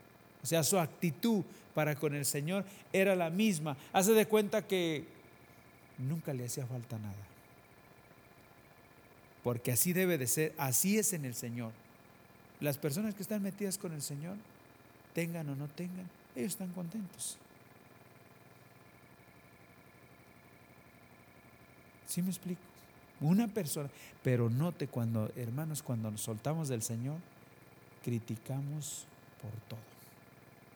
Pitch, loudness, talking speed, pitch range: 145 Hz, -35 LUFS, 120 wpm, 120-180 Hz